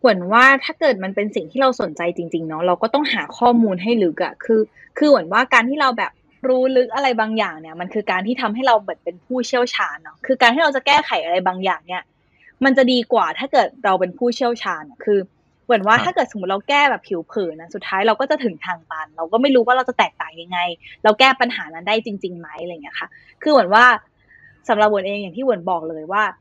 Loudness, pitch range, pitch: -18 LUFS, 185-255 Hz, 225 Hz